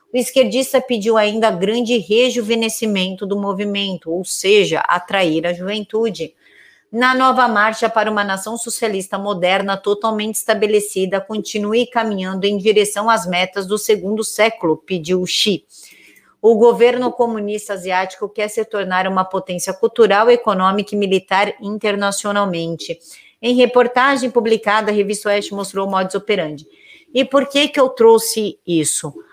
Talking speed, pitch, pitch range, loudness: 135 wpm, 210 Hz, 195-230 Hz, -16 LUFS